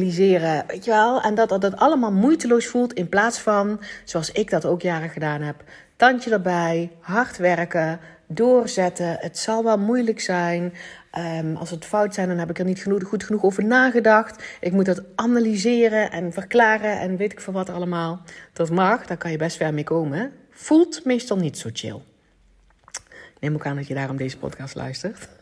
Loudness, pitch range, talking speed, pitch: -21 LUFS, 165-220 Hz, 190 wpm, 185 Hz